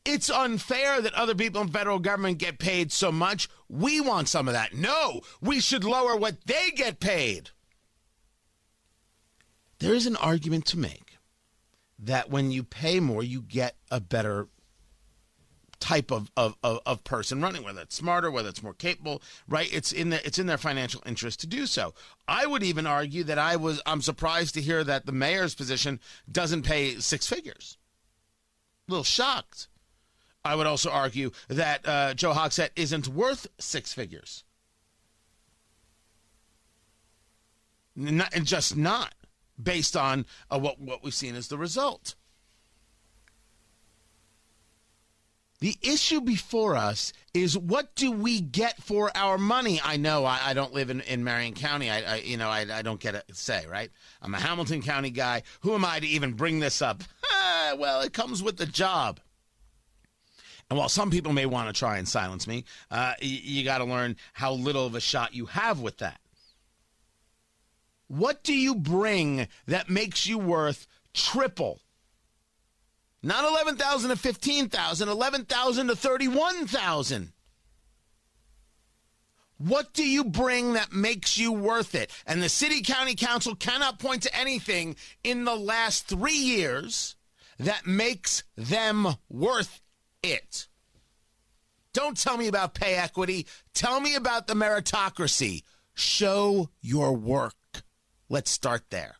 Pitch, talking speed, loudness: 155 Hz, 150 wpm, -27 LUFS